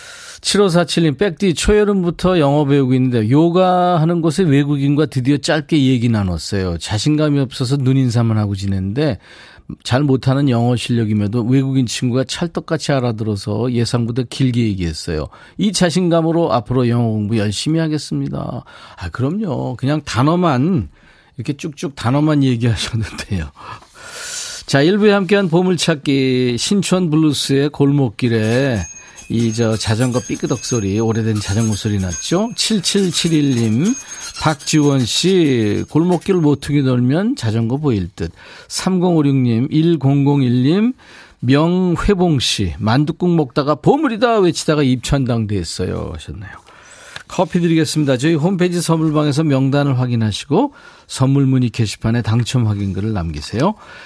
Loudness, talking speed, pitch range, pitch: -16 LUFS, 300 characters per minute, 115-170 Hz, 140 Hz